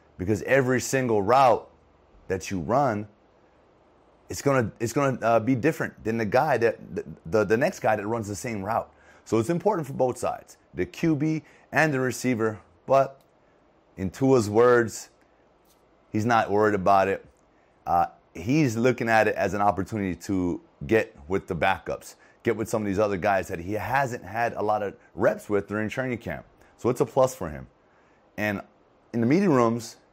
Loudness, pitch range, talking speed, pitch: -25 LUFS, 100-130 Hz, 180 wpm, 110 Hz